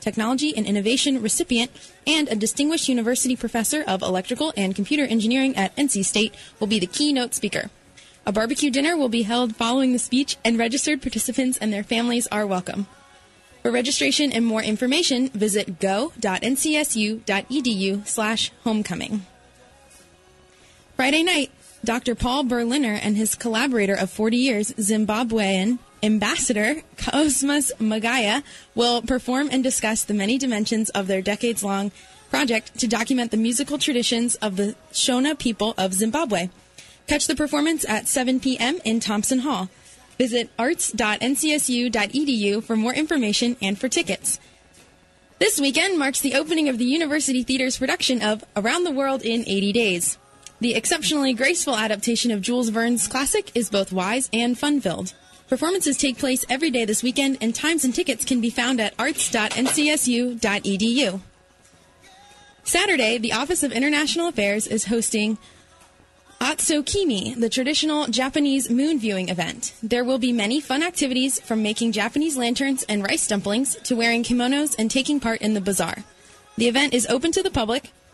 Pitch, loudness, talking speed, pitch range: 240 Hz, -22 LUFS, 150 wpm, 215-275 Hz